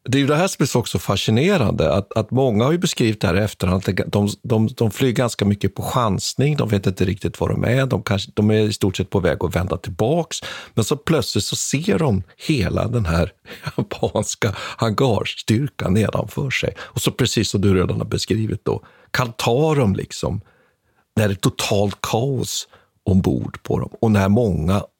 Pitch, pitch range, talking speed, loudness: 110 Hz, 95-125 Hz, 200 wpm, -20 LUFS